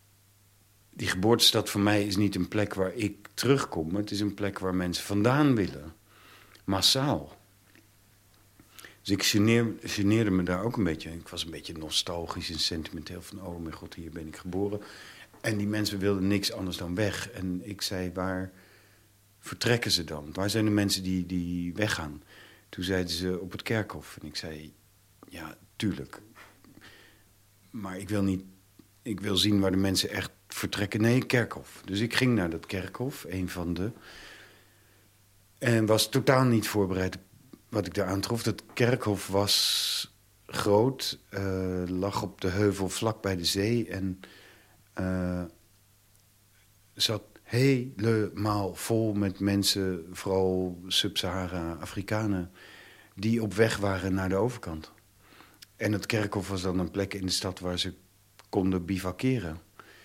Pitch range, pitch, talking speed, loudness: 95-105 Hz, 100 Hz, 155 wpm, -29 LUFS